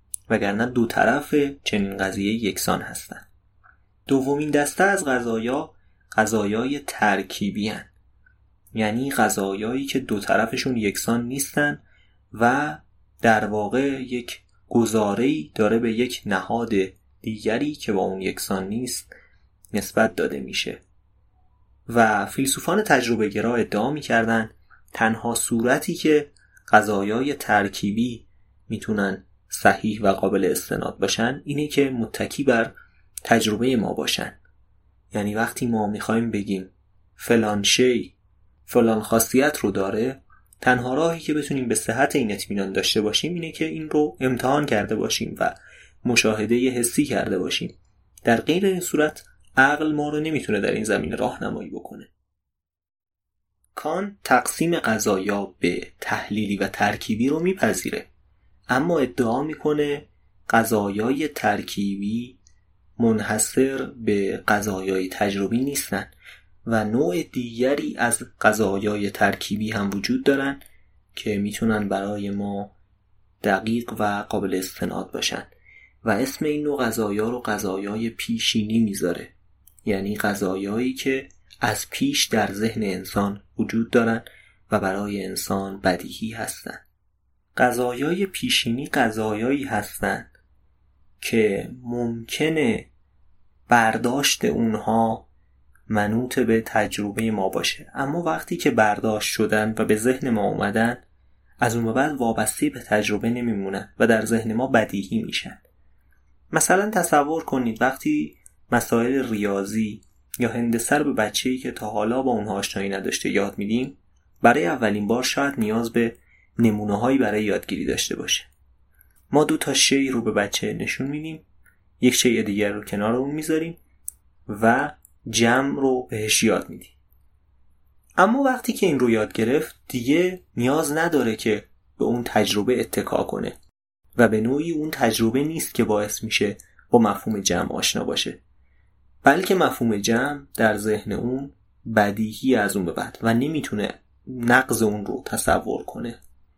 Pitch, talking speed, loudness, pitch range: 110 Hz, 125 wpm, -23 LUFS, 100-130 Hz